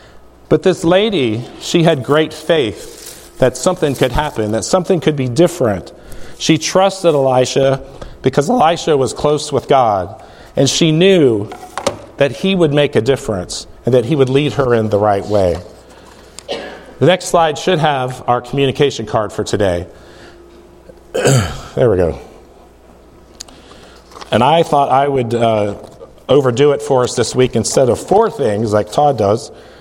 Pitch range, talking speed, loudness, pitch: 110-155 Hz, 155 wpm, -14 LUFS, 135 Hz